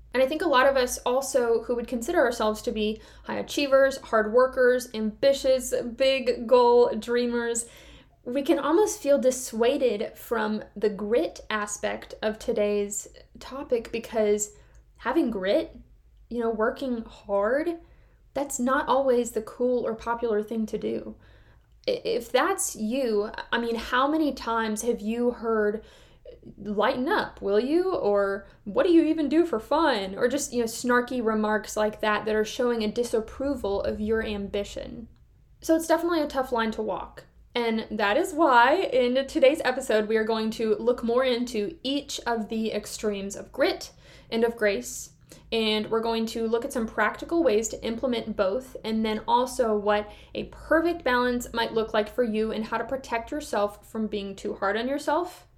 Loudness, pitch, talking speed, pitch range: -26 LUFS, 235 Hz, 170 wpm, 215-265 Hz